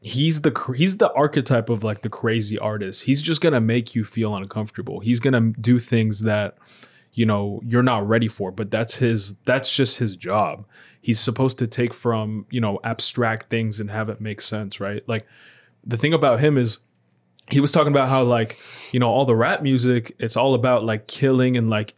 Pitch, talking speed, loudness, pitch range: 115 Hz, 210 wpm, -21 LUFS, 110-125 Hz